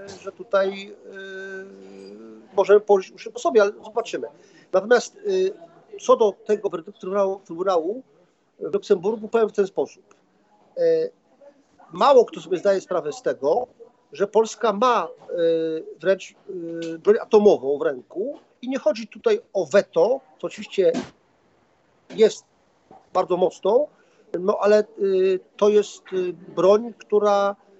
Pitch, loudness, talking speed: 210 Hz, -22 LUFS, 130 wpm